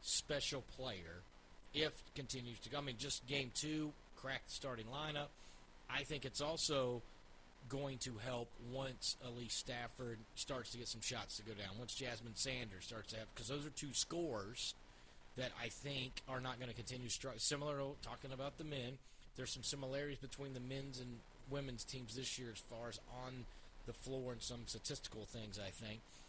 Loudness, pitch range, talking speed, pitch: -45 LUFS, 115-135 Hz, 185 wpm, 125 Hz